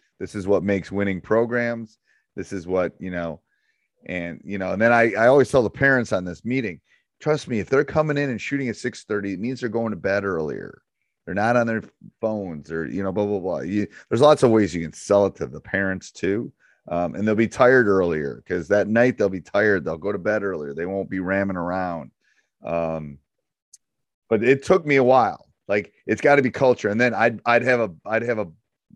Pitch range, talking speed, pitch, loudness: 95-120 Hz, 230 wpm, 105 Hz, -22 LUFS